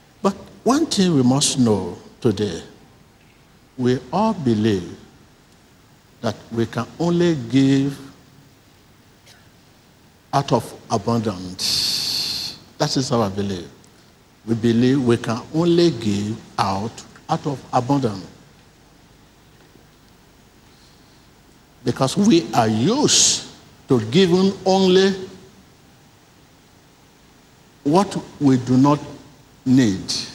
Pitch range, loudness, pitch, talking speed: 115-165 Hz, -19 LUFS, 130 Hz, 85 wpm